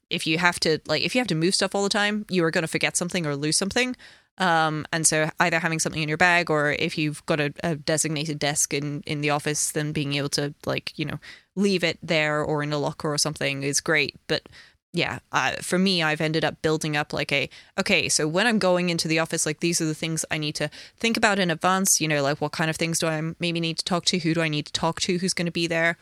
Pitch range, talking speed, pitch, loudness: 150-175 Hz, 275 wpm, 160 Hz, -24 LUFS